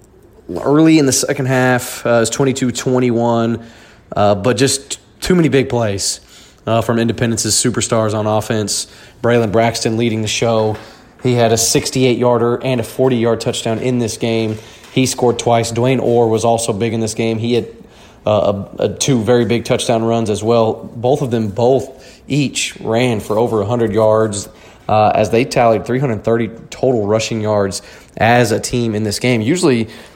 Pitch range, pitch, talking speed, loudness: 110-125 Hz, 115 Hz, 180 wpm, -15 LUFS